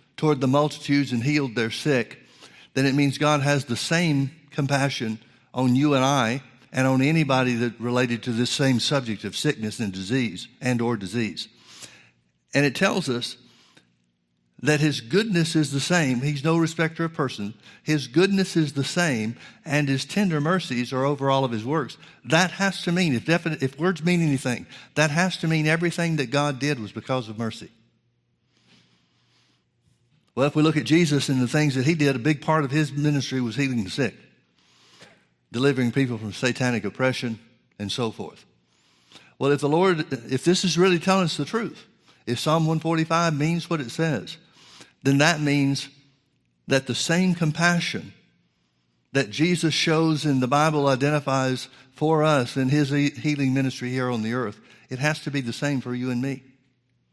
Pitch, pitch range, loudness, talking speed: 140 Hz, 120-155 Hz, -23 LUFS, 180 wpm